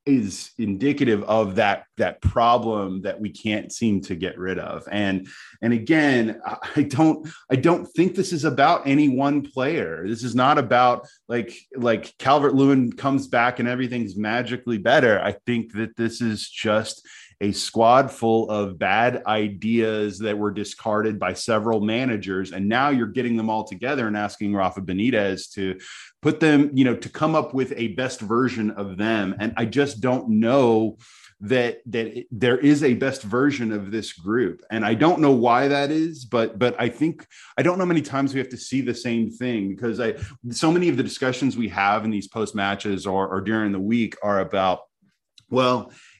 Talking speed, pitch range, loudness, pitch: 190 wpm, 105-130 Hz, -22 LUFS, 115 Hz